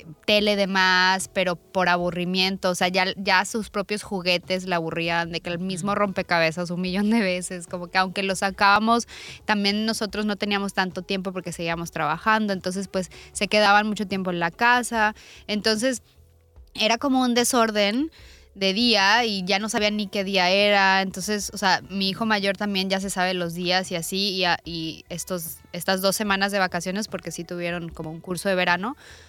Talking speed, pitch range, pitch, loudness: 190 wpm, 180-205 Hz, 190 Hz, -23 LUFS